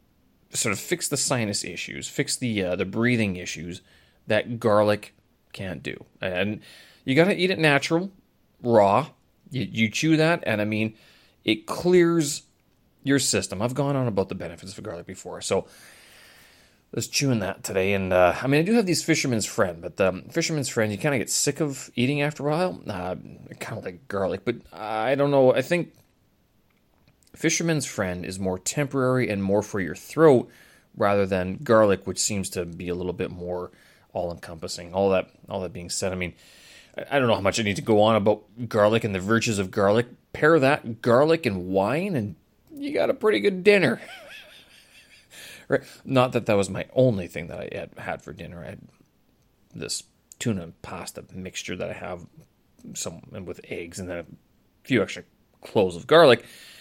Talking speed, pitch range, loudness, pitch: 190 wpm, 95-140 Hz, -24 LUFS, 110 Hz